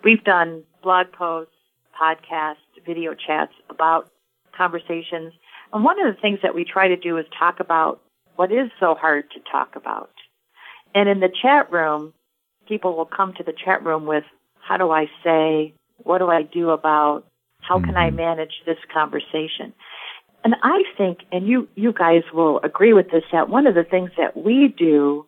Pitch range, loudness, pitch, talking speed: 160-190 Hz, -20 LUFS, 170 Hz, 180 wpm